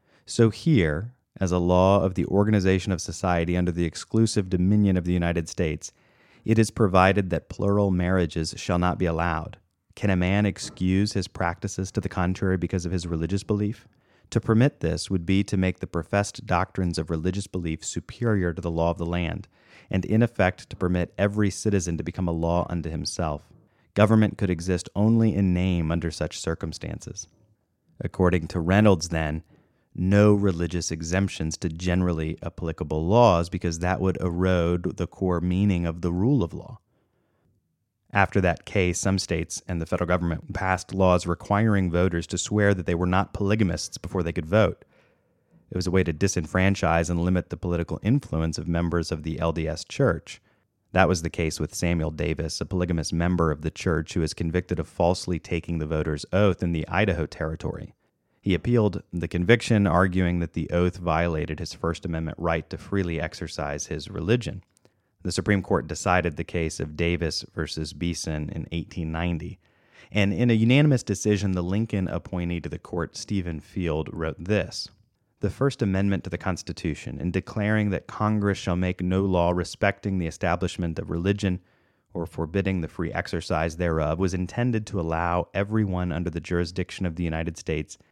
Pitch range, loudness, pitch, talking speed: 85-100 Hz, -25 LUFS, 90 Hz, 175 wpm